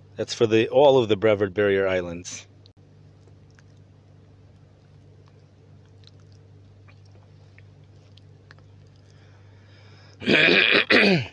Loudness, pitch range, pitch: -19 LUFS, 100-110 Hz, 105 Hz